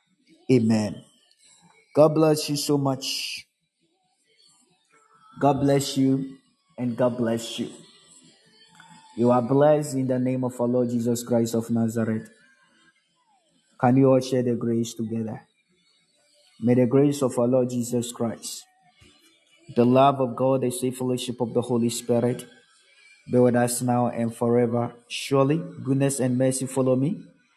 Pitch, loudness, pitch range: 125 Hz, -23 LUFS, 120-135 Hz